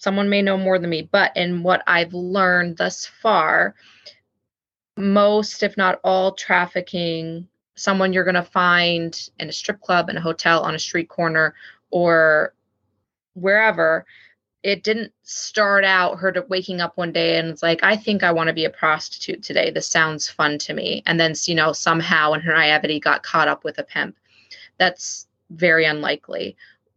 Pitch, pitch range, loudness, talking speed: 175 Hz, 160-190 Hz, -19 LUFS, 175 wpm